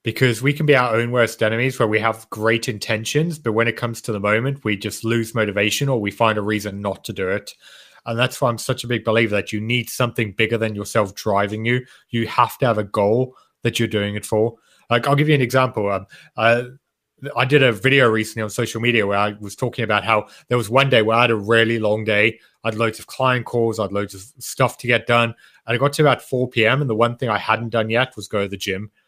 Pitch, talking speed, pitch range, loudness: 115 Hz, 260 wpm, 110-125 Hz, -19 LUFS